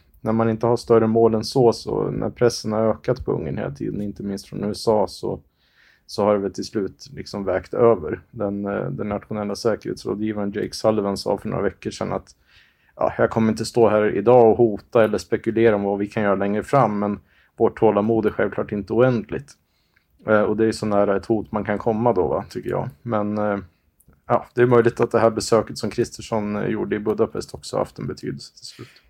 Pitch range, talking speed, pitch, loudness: 100-115 Hz, 210 wpm, 110 Hz, -21 LUFS